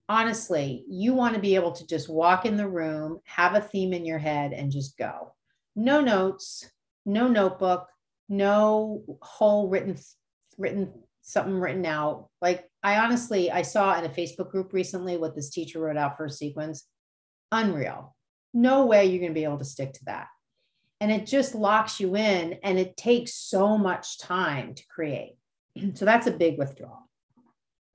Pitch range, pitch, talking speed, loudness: 160-210 Hz, 185 Hz, 175 wpm, -26 LUFS